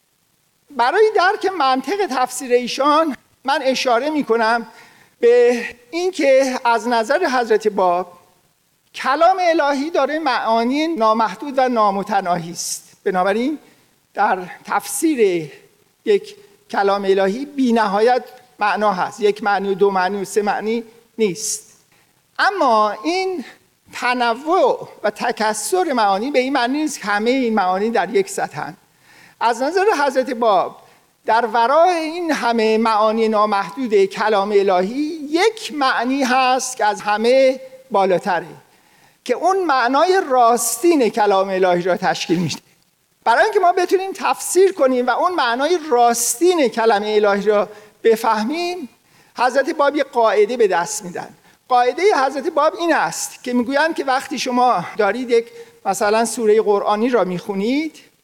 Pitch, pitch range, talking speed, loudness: 245 Hz, 210-295 Hz, 130 wpm, -17 LUFS